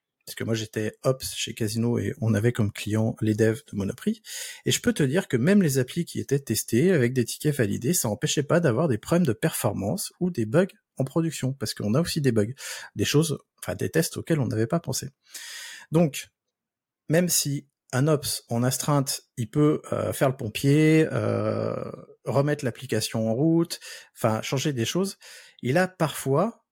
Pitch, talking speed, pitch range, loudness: 135 Hz, 195 wpm, 115-165 Hz, -25 LUFS